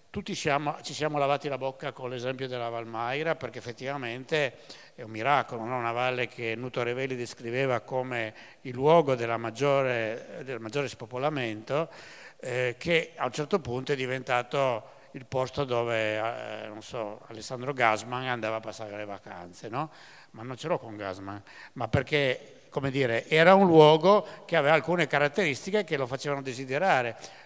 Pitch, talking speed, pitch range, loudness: 130 Hz, 160 wpm, 115-145 Hz, -28 LUFS